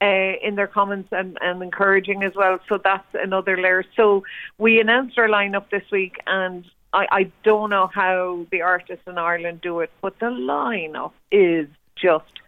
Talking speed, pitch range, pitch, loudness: 180 wpm, 180-200 Hz, 195 Hz, -20 LUFS